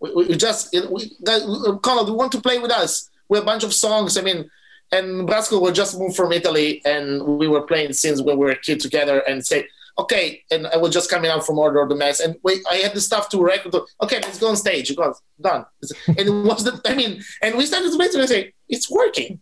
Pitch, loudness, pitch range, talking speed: 190 Hz, -19 LUFS, 160-220 Hz, 255 wpm